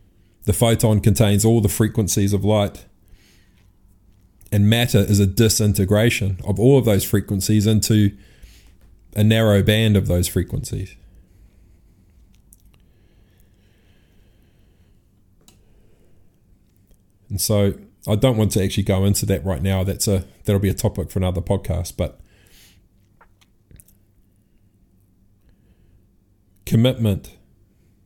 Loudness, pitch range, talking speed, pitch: -19 LUFS, 95-105 Hz, 105 wpm, 100 Hz